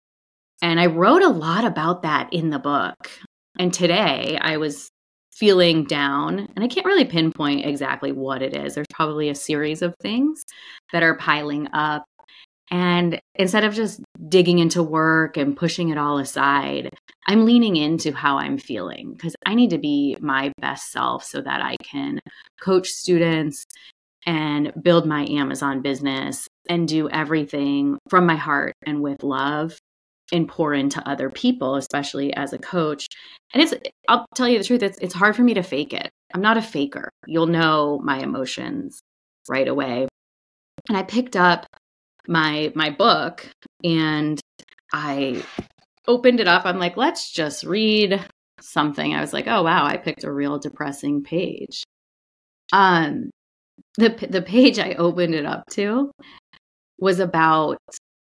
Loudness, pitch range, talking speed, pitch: -21 LUFS, 145-195 Hz, 160 wpm, 165 Hz